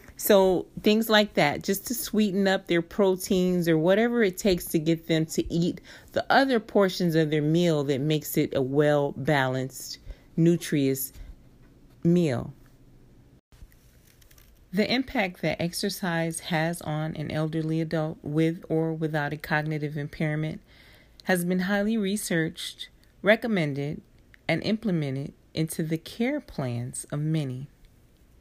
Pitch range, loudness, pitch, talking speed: 150-190 Hz, -26 LUFS, 165 Hz, 130 wpm